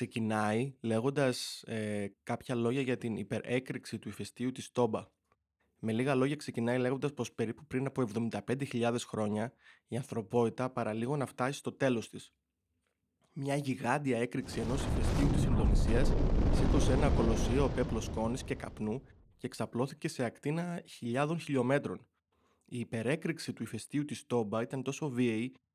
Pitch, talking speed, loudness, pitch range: 120 Hz, 140 wpm, -34 LUFS, 115-135 Hz